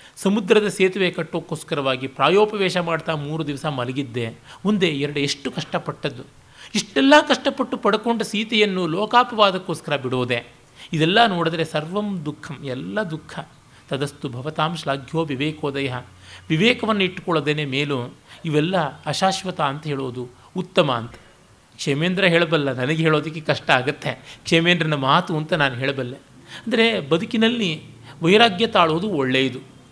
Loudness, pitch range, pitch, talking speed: -21 LUFS, 140-185 Hz, 160 Hz, 105 wpm